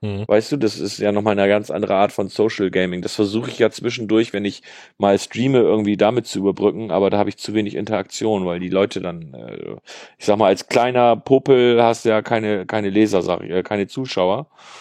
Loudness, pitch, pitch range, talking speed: -19 LUFS, 105 Hz, 100-115 Hz, 205 wpm